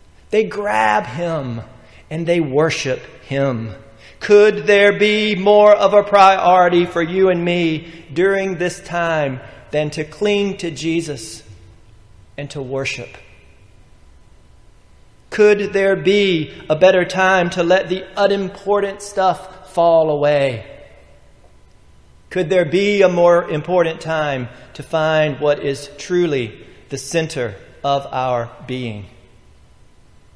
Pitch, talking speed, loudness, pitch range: 160 Hz, 115 wpm, -16 LUFS, 130-185 Hz